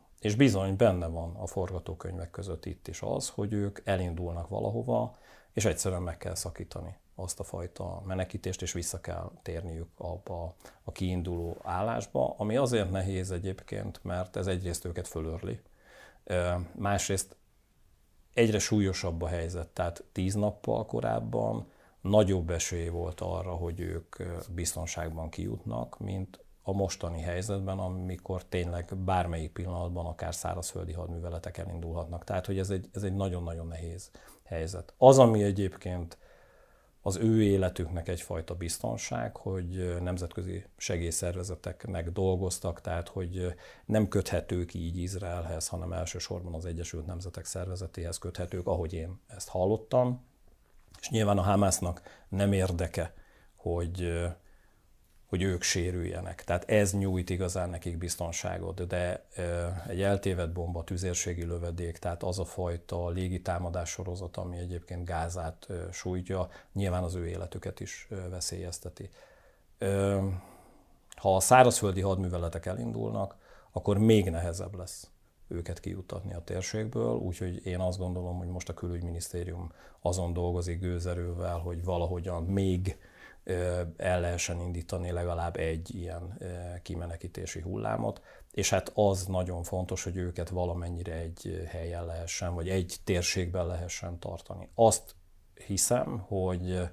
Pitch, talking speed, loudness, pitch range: 90 Hz, 125 wpm, -32 LUFS, 85-95 Hz